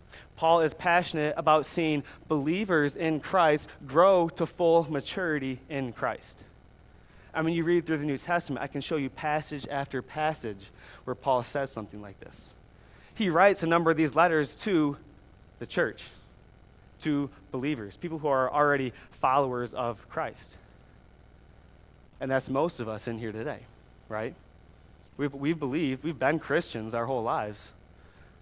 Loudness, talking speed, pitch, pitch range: -28 LUFS, 150 wpm, 140 Hz, 110-155 Hz